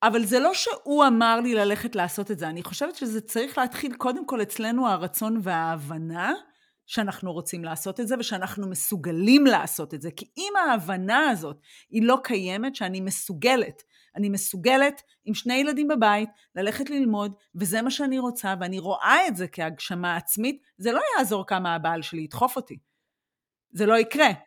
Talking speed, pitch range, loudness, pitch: 165 wpm, 185-255 Hz, -25 LUFS, 215 Hz